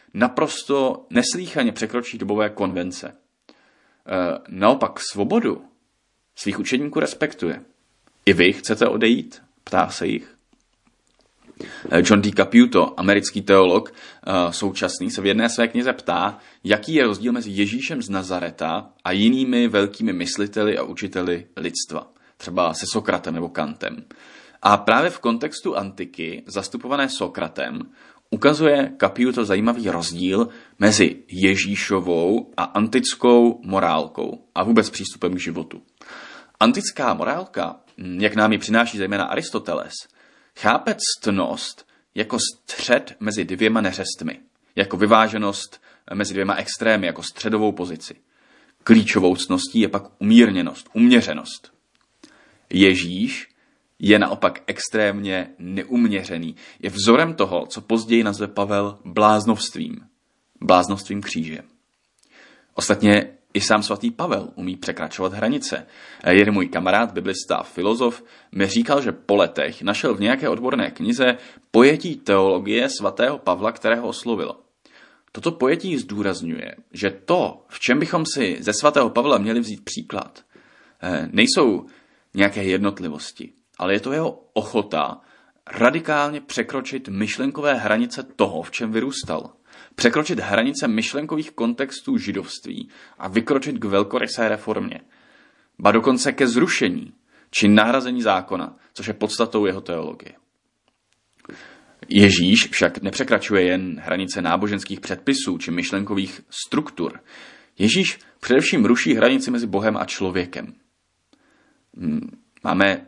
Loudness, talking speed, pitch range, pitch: -20 LUFS, 115 wpm, 100-140 Hz, 110 Hz